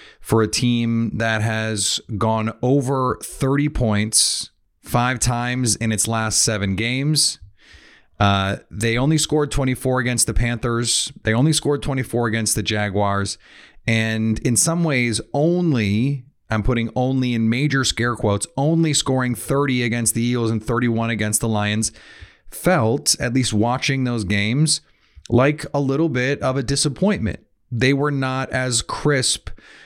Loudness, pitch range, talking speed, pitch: -20 LUFS, 110-135 Hz, 145 wpm, 120 Hz